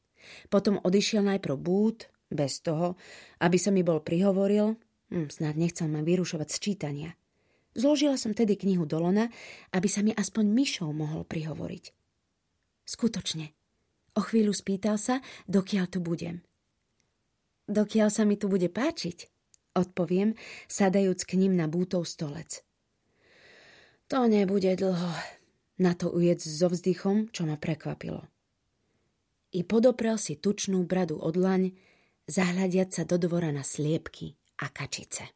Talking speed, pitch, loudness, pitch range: 130 wpm, 185 Hz, -28 LUFS, 165-205 Hz